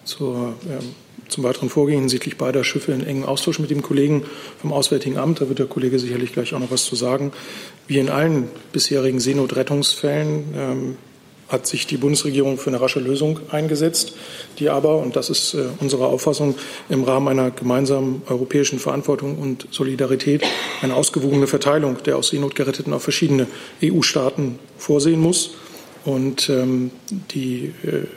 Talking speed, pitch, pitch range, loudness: 160 wpm, 140 Hz, 130-150 Hz, -20 LUFS